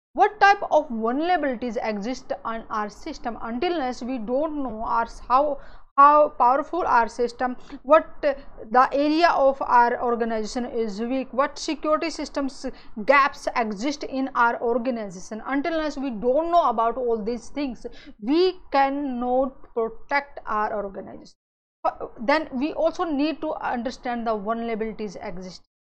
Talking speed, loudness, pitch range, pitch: 135 wpm, -23 LUFS, 230-295 Hz, 255 Hz